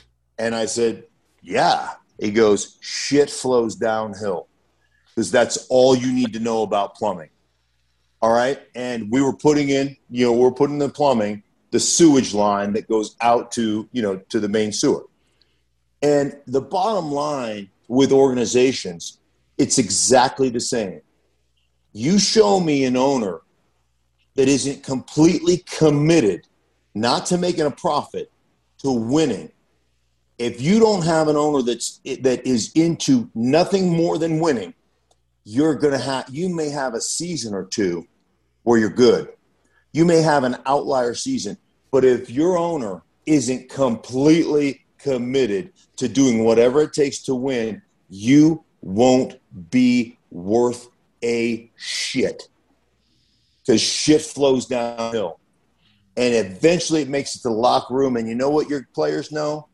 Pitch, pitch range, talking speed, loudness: 130 Hz, 115-150 Hz, 145 wpm, -19 LUFS